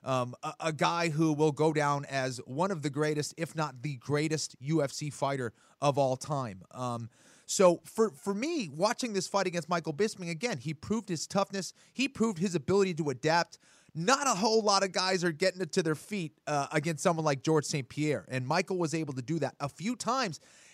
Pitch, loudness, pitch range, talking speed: 160 Hz, -31 LUFS, 145-190 Hz, 210 wpm